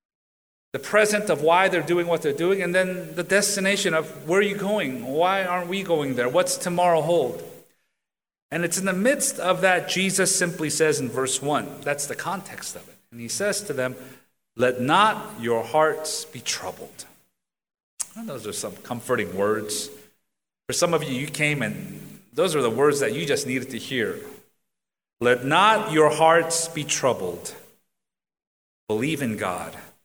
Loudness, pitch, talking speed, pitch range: -23 LUFS, 165 Hz, 175 wpm, 130-185 Hz